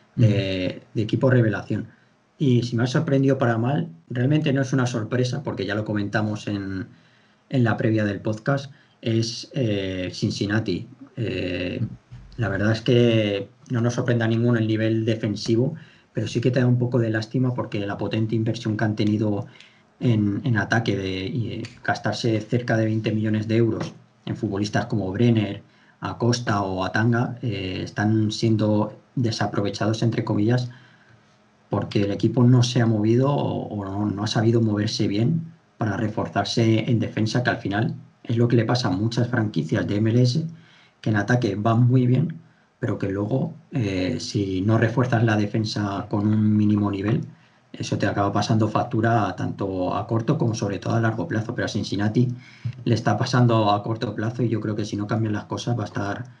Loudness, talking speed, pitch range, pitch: -23 LUFS, 180 wpm, 105-125 Hz, 115 Hz